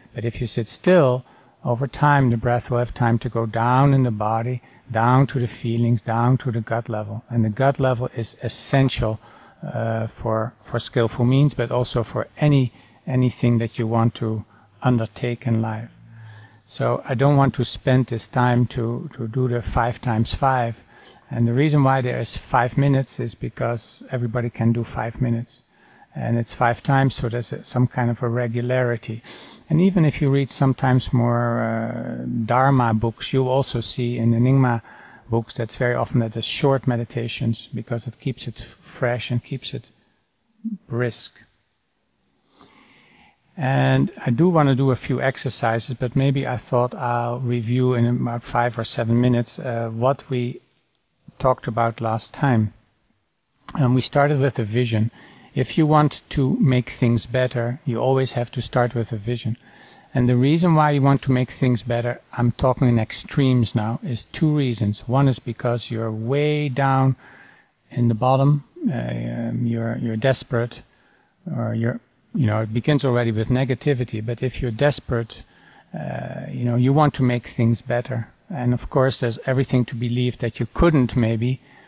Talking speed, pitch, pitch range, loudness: 175 wpm, 120 Hz, 115-130 Hz, -21 LUFS